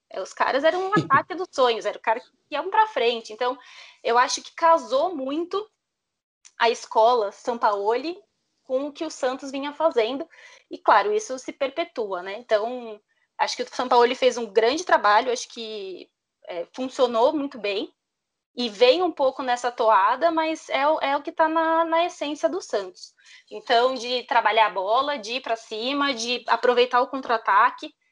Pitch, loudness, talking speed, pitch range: 260 Hz, -23 LUFS, 175 wpm, 235-325 Hz